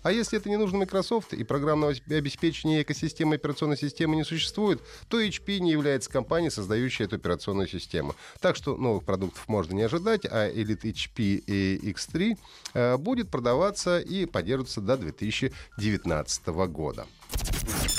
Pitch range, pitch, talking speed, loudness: 105-165 Hz, 135 Hz, 140 wpm, -28 LUFS